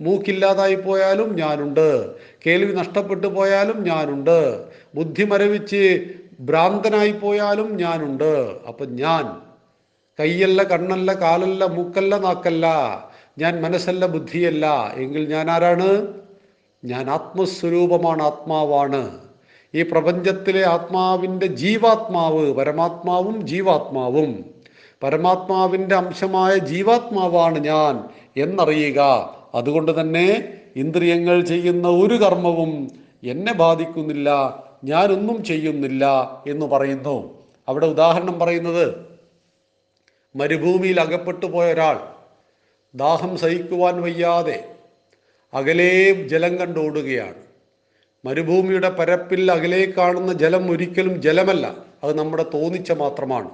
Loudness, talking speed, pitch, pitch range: -19 LUFS, 80 wpm, 175 Hz, 155-190 Hz